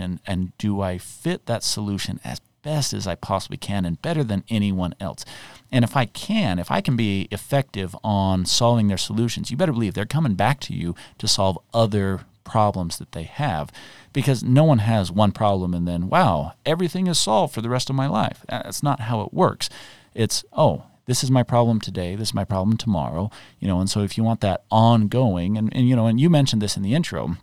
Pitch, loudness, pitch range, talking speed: 110 Hz, -22 LUFS, 95-125 Hz, 220 wpm